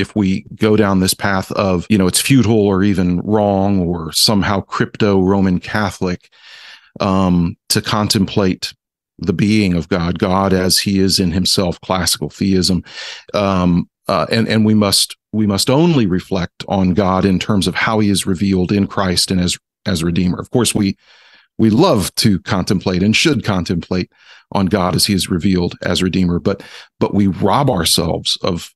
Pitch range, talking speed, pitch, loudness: 90-105 Hz, 175 wpm, 95 Hz, -15 LUFS